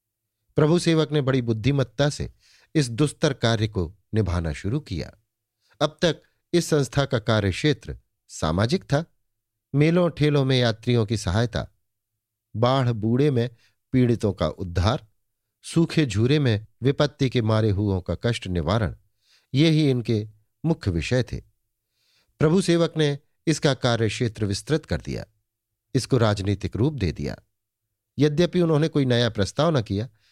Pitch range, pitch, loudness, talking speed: 105-145 Hz, 115 Hz, -23 LUFS, 140 wpm